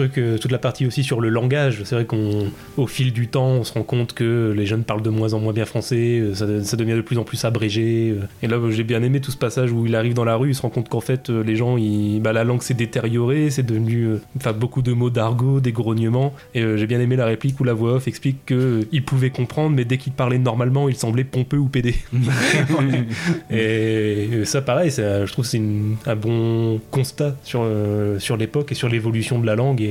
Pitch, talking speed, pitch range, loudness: 120 Hz, 245 wpm, 110-130 Hz, -20 LUFS